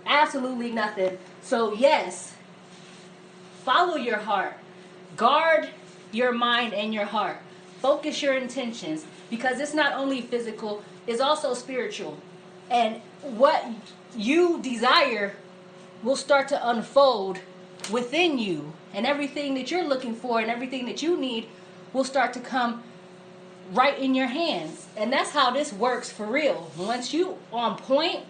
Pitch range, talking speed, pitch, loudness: 185-270 Hz, 135 wpm, 235 Hz, -25 LUFS